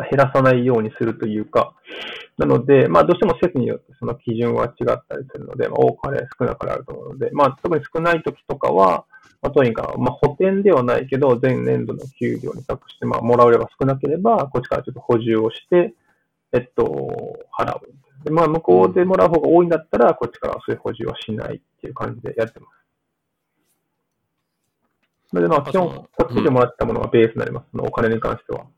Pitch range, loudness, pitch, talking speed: 115-165 Hz, -19 LUFS, 130 Hz, 415 characters per minute